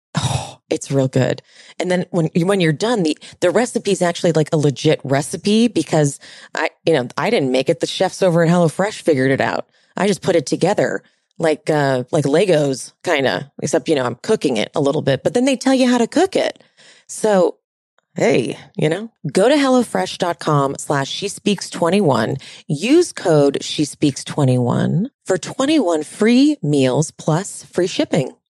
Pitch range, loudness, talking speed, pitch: 150-200 Hz, -18 LUFS, 180 wpm, 170 Hz